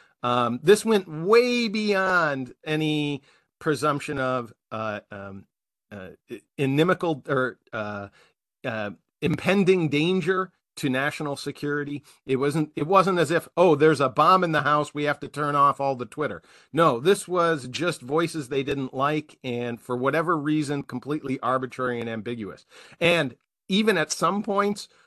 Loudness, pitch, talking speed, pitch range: -24 LUFS, 150 Hz, 150 wpm, 130-170 Hz